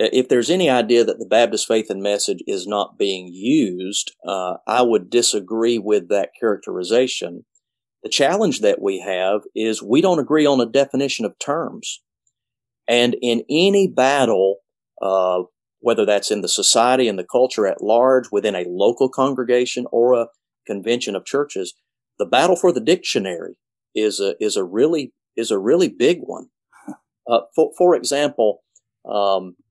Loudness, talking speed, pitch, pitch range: -19 LUFS, 160 wpm, 120 Hz, 105-140 Hz